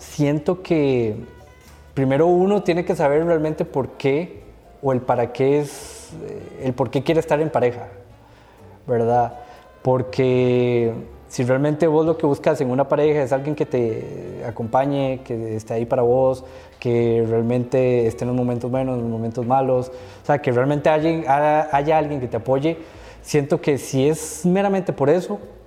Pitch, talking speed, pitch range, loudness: 135 Hz, 170 wpm, 120-150 Hz, -20 LUFS